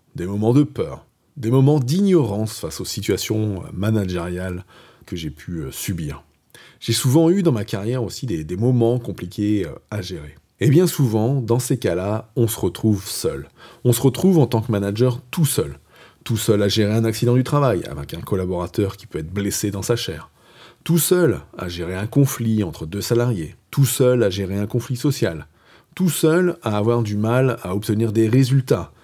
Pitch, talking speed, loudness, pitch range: 115 Hz, 190 wpm, -20 LUFS, 100-130 Hz